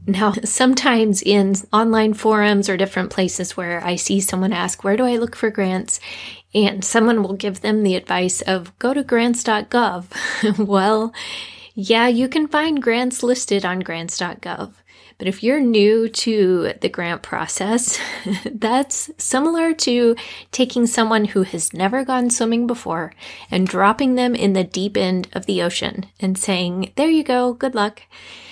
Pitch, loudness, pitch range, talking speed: 215 Hz, -18 LUFS, 195-240 Hz, 160 wpm